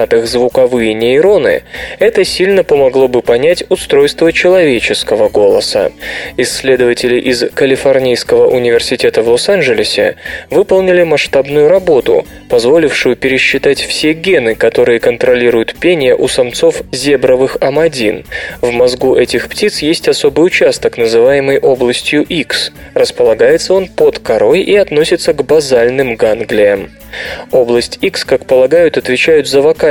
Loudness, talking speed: -10 LUFS, 110 wpm